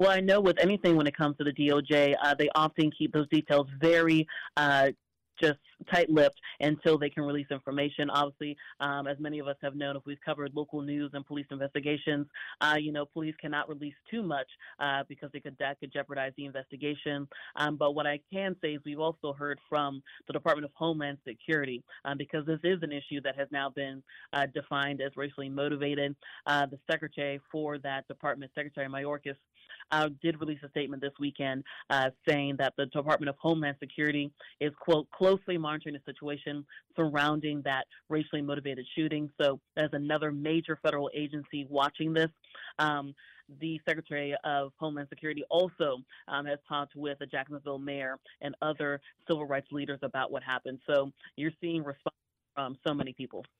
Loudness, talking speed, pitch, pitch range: -32 LUFS, 185 wpm, 145 Hz, 140-155 Hz